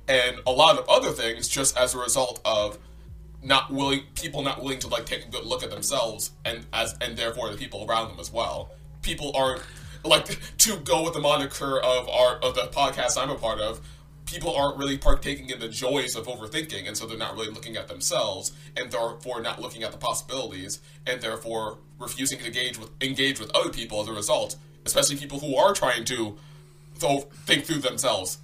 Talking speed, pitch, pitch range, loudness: 205 wpm, 125 Hz, 110-140 Hz, -26 LUFS